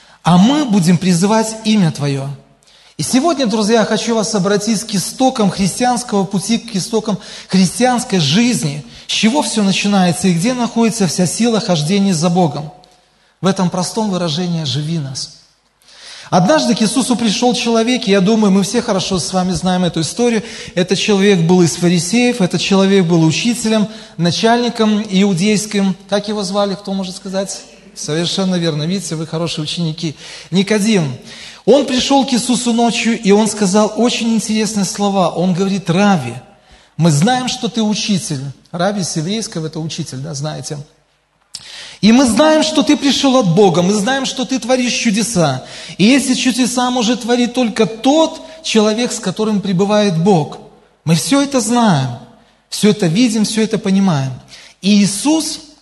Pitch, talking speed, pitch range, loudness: 200 Hz, 155 wpm, 180-230 Hz, -14 LUFS